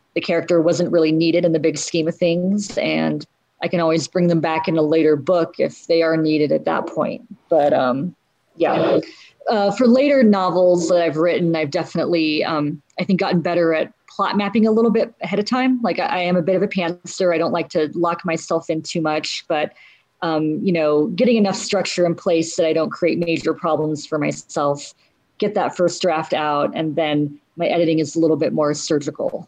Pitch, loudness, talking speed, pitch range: 170 Hz, -19 LUFS, 215 wpm, 160-185 Hz